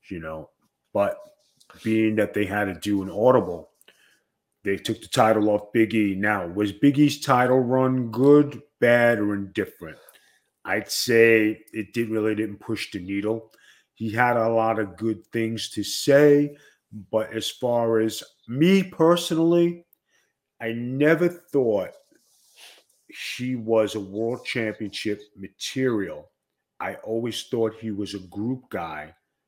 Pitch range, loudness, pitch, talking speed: 105-130 Hz, -23 LUFS, 115 Hz, 135 wpm